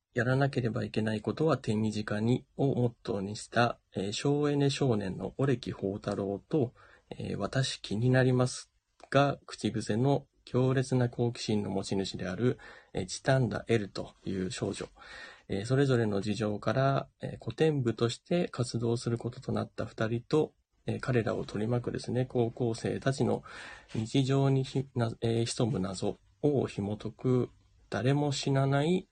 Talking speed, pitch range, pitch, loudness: 275 characters per minute, 105-135 Hz, 120 Hz, -31 LUFS